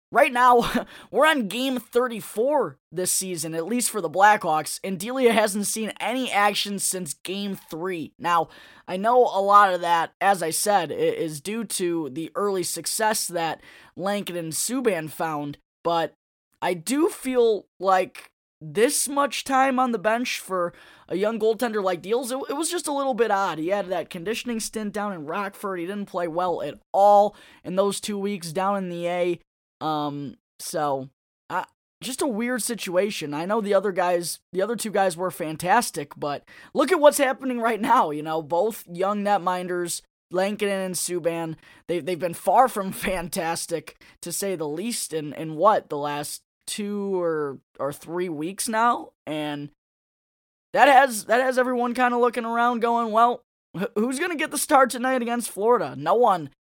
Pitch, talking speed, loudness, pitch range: 195 Hz, 175 wpm, -24 LUFS, 170-235 Hz